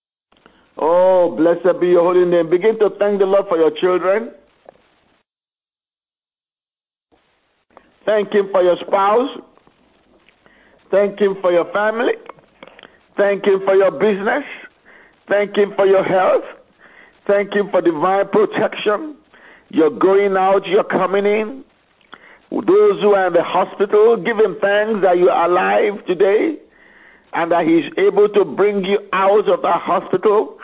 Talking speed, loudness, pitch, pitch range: 135 wpm, -16 LUFS, 200 Hz, 185-220 Hz